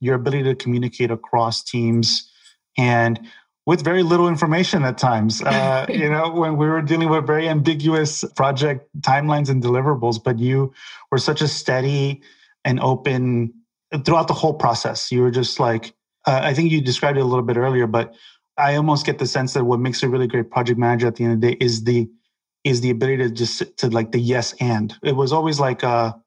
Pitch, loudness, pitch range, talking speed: 130 Hz, -19 LUFS, 120-150 Hz, 195 wpm